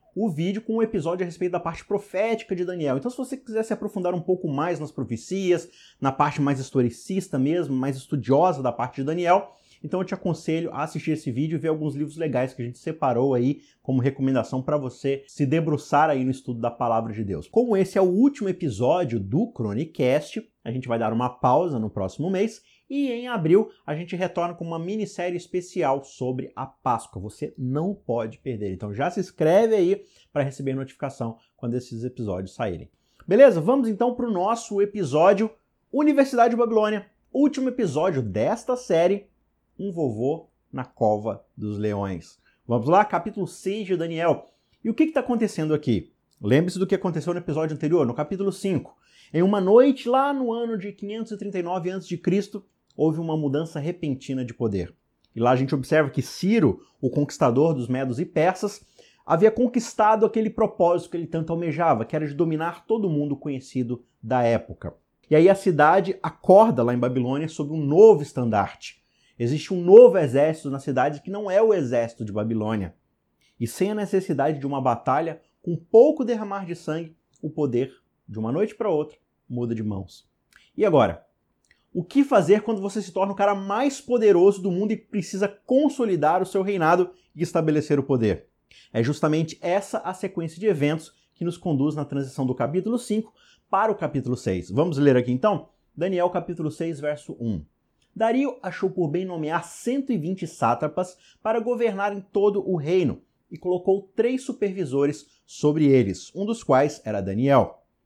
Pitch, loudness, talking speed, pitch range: 165 Hz, -23 LUFS, 180 wpm, 135-200 Hz